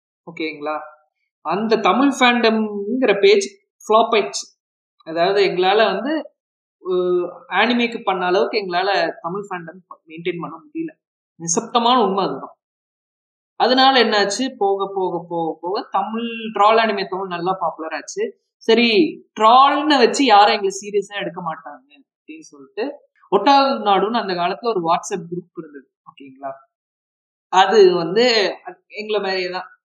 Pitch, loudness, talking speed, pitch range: 205 Hz, -18 LUFS, 120 wpm, 175-255 Hz